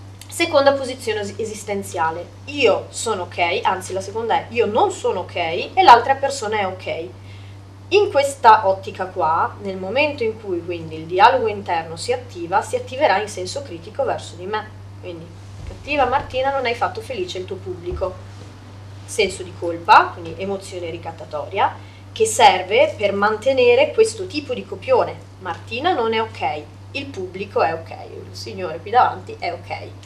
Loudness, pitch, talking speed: -19 LUFS, 210 Hz, 160 wpm